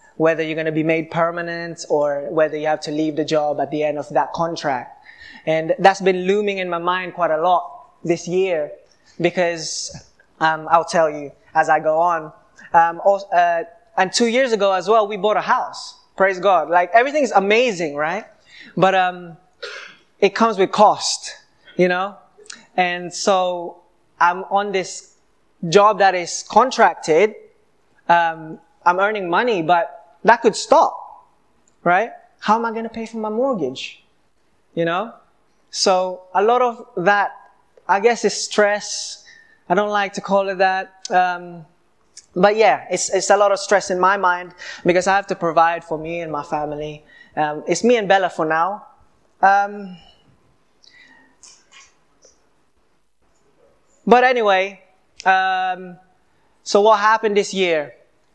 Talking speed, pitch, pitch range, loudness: 155 wpm, 185 Hz, 170-205 Hz, -18 LUFS